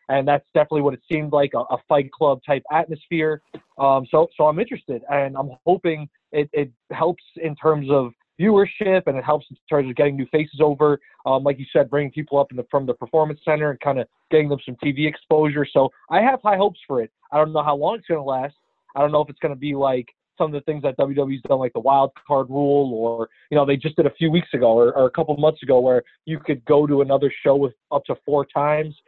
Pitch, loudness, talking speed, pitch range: 145 Hz, -20 LUFS, 255 wpm, 135-155 Hz